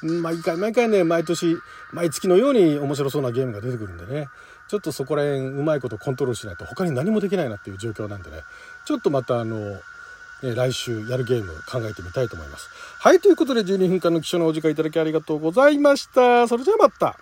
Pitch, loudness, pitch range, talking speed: 160 Hz, -21 LUFS, 125-210 Hz, 470 characters per minute